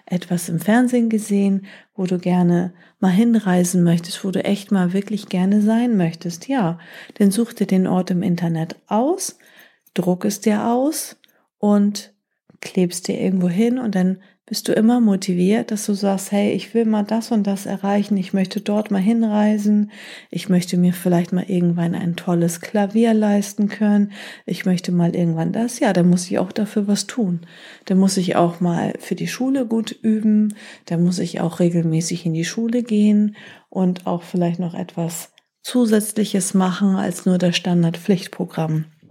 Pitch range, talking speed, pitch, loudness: 180-215 Hz, 170 wpm, 195 Hz, -19 LUFS